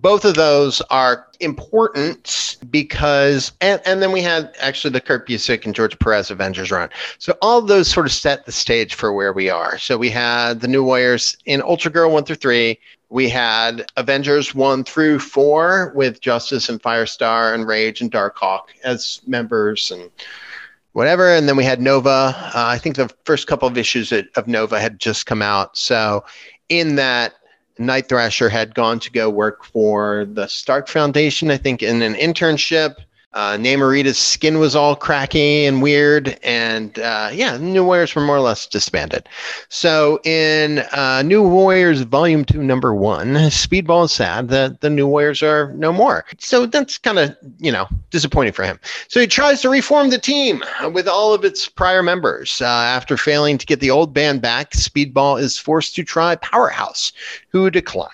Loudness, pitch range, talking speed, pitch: -16 LUFS, 120-160 Hz, 185 wpm, 140 Hz